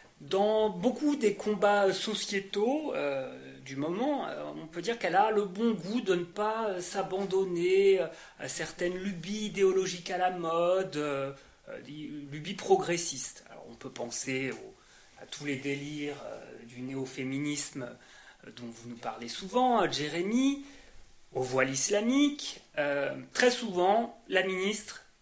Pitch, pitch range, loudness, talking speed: 185 Hz, 145-210 Hz, -31 LUFS, 150 wpm